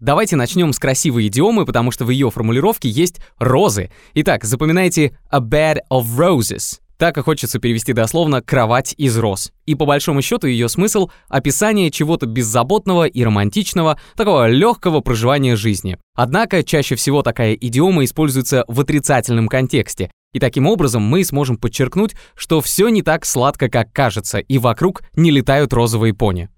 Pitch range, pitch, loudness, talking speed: 120-160 Hz, 135 Hz, -16 LUFS, 155 wpm